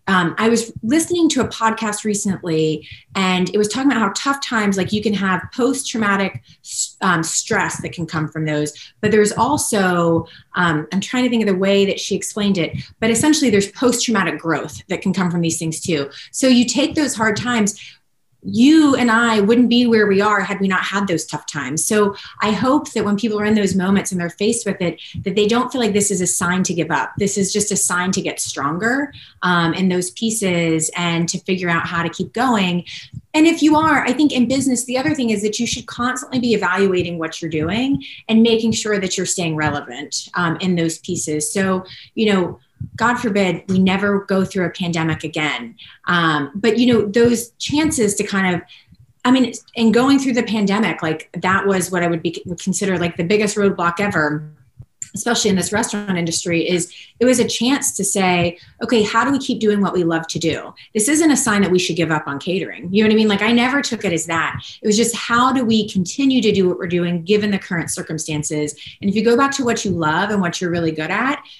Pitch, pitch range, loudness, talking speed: 195 Hz, 170-230 Hz, -18 LUFS, 230 wpm